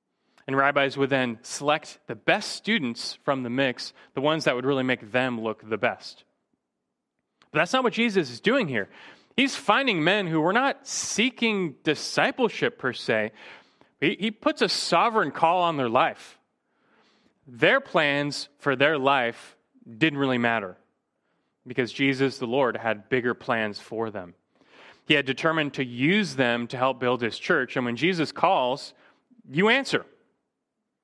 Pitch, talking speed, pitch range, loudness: 140 Hz, 155 wpm, 125-175 Hz, -25 LUFS